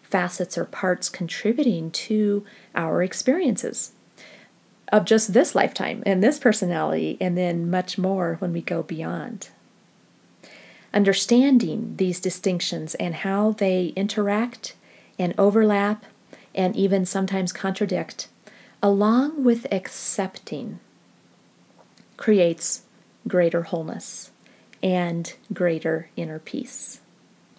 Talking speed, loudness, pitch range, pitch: 100 wpm, -23 LUFS, 175-210 Hz, 190 Hz